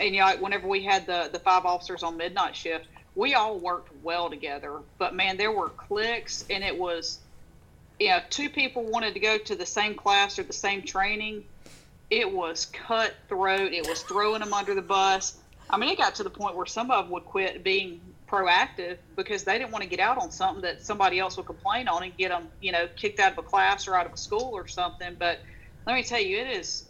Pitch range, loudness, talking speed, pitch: 180-215 Hz, -27 LUFS, 235 wpm, 195 Hz